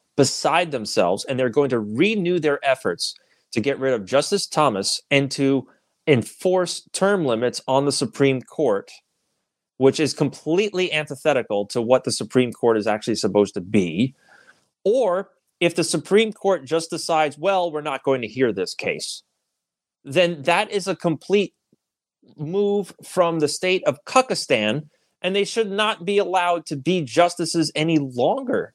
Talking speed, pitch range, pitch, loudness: 155 wpm, 135-185 Hz, 155 Hz, -21 LUFS